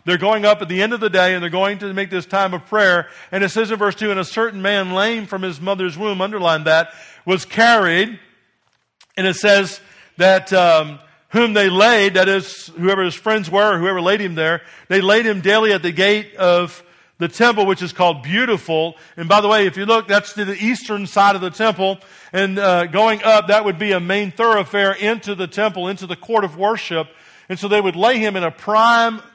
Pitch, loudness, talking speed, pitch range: 195 Hz, -16 LUFS, 230 wpm, 185-210 Hz